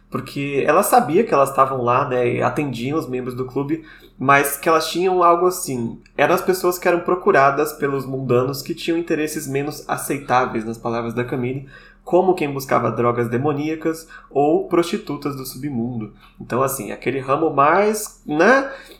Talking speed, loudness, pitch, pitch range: 165 wpm, -19 LUFS, 140 Hz, 125-170 Hz